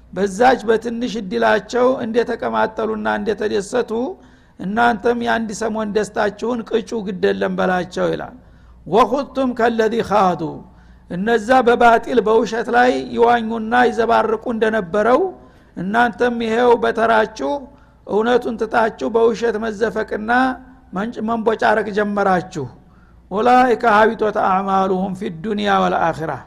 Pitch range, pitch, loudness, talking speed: 210-235 Hz, 225 Hz, -17 LUFS, 85 wpm